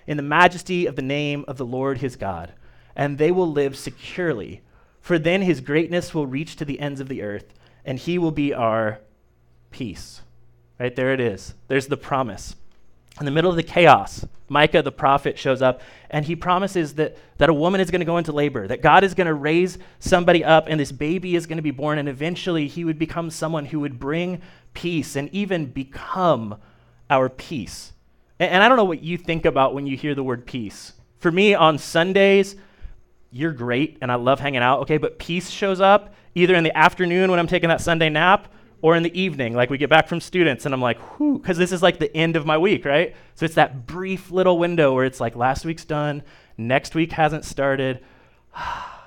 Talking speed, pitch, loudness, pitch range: 215 wpm, 150 Hz, -20 LUFS, 130-175 Hz